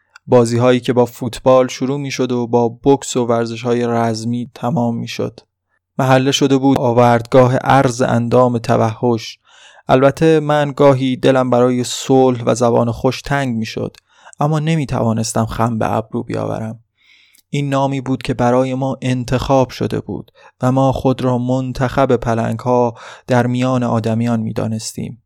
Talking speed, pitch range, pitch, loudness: 155 wpm, 120-130 Hz, 125 Hz, -16 LUFS